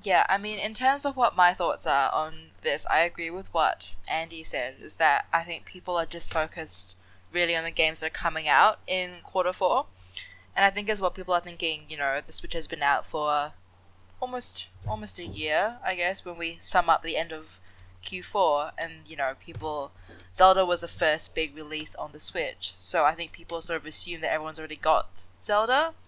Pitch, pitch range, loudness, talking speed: 165 Hz, 140-180 Hz, -27 LUFS, 215 wpm